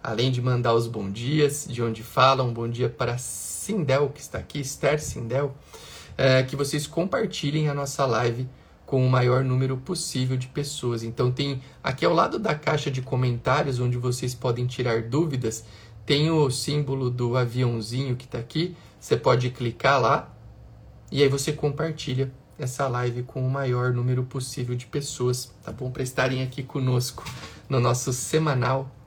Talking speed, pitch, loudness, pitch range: 165 wpm, 130 Hz, -25 LUFS, 125-140 Hz